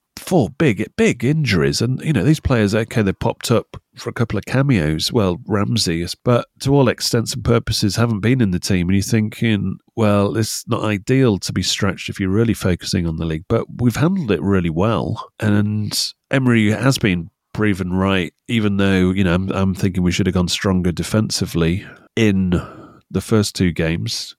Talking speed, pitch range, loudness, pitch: 190 wpm, 95-115 Hz, -18 LUFS, 105 Hz